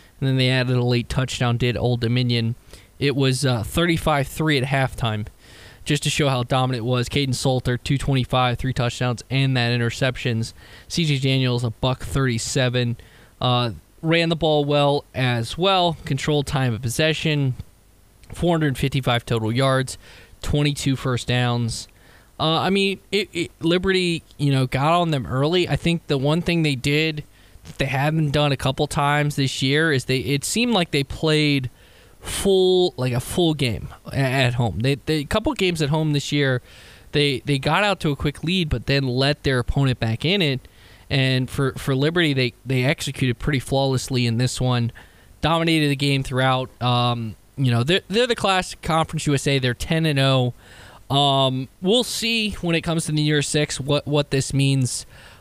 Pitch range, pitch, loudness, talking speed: 120-150 Hz, 135 Hz, -21 LUFS, 175 wpm